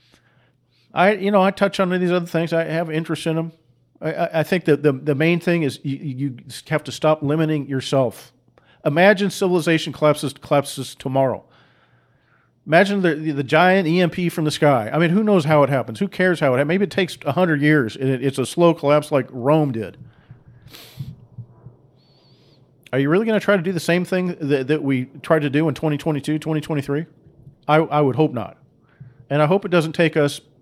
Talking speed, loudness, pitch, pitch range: 205 wpm, -19 LUFS, 150 Hz, 135-170 Hz